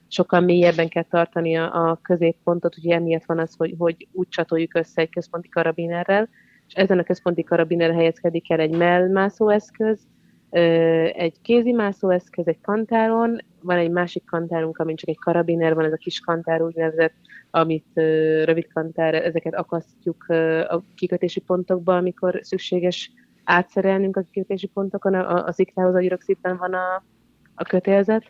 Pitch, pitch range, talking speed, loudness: 175 Hz, 165-185 Hz, 150 wpm, -21 LUFS